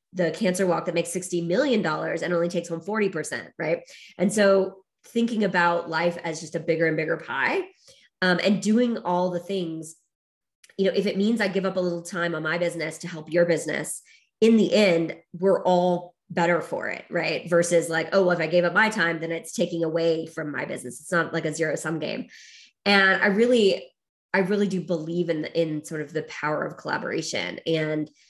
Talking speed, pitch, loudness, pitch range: 210 wpm, 175 Hz, -24 LUFS, 165-195 Hz